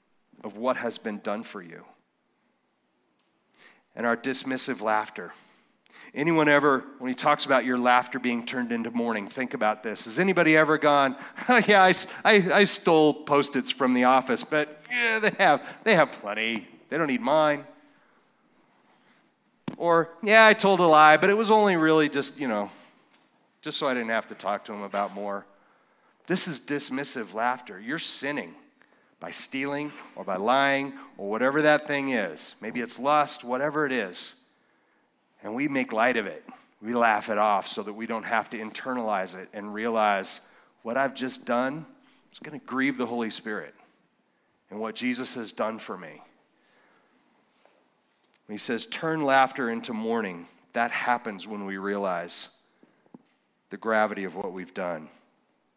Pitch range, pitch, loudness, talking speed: 115-155 Hz, 135 Hz, -25 LUFS, 165 wpm